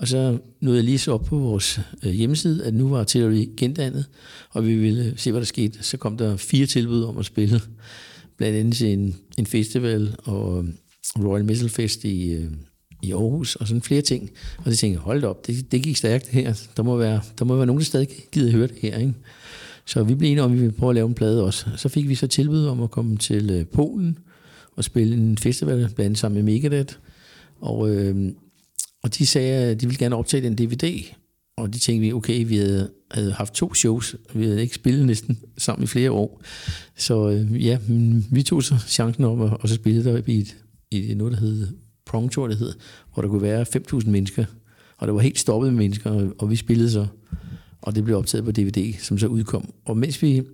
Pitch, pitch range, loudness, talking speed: 115 Hz, 105-125 Hz, -22 LUFS, 225 wpm